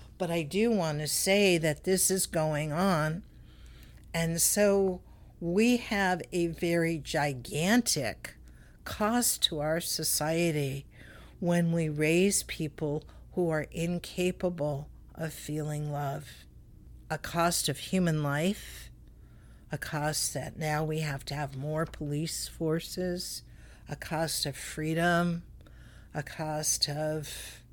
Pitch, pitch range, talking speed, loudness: 160 Hz, 150-175 Hz, 120 wpm, -30 LUFS